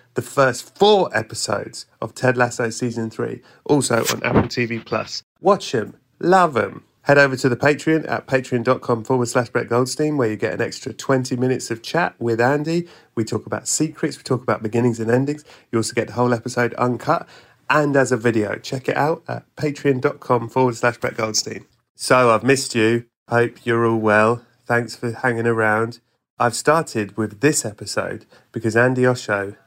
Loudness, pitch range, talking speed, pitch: -20 LUFS, 115-135 Hz, 180 wpm, 120 Hz